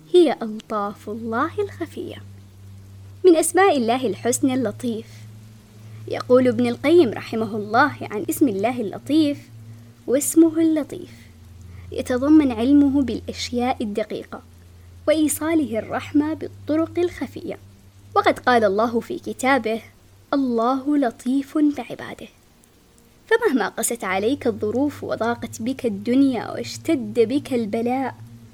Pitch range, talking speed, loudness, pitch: 185-285 Hz, 95 wpm, -21 LUFS, 240 Hz